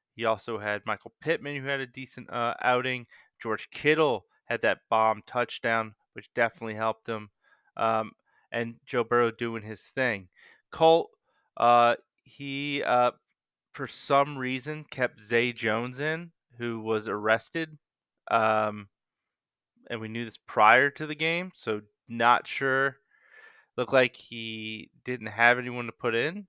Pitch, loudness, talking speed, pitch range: 120 Hz, -27 LUFS, 145 wpm, 110-140 Hz